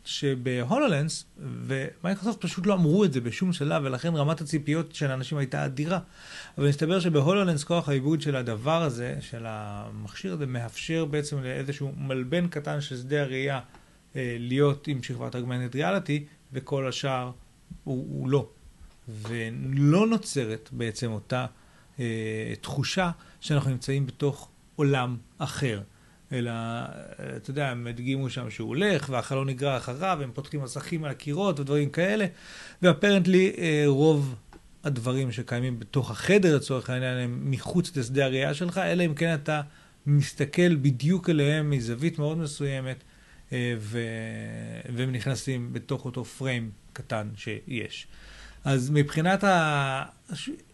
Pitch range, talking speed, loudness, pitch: 125-160 Hz, 130 wpm, -28 LUFS, 140 Hz